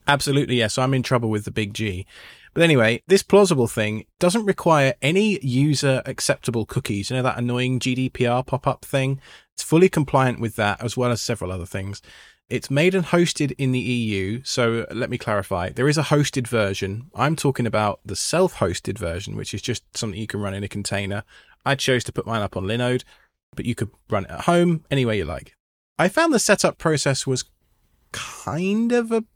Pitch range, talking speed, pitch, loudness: 110-145 Hz, 210 wpm, 125 Hz, -22 LUFS